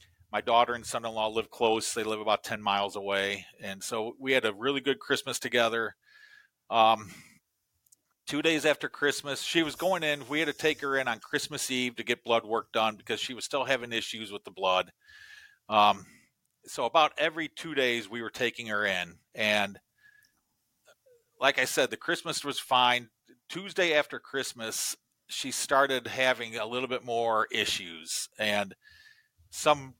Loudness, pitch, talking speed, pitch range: -29 LUFS, 125 Hz, 175 wpm, 110-150 Hz